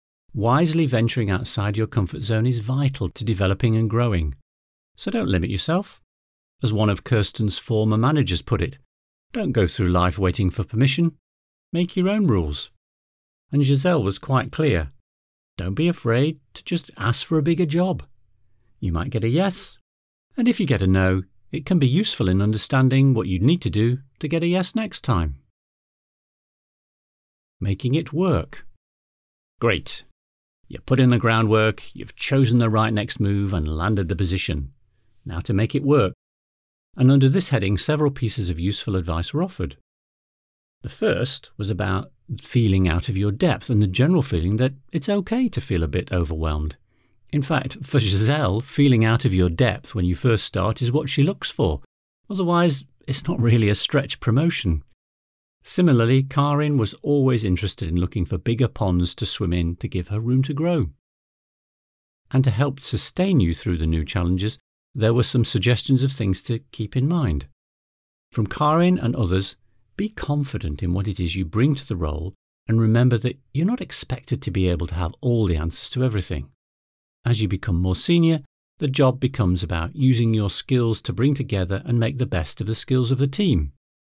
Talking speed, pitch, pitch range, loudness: 180 wpm, 110 Hz, 90-135 Hz, -22 LUFS